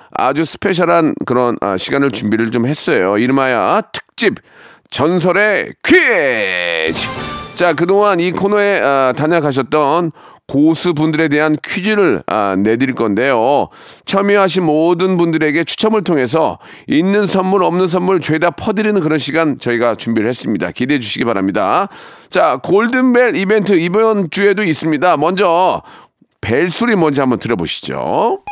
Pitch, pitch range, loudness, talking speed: 170 Hz, 140-200 Hz, -14 LUFS, 300 characters per minute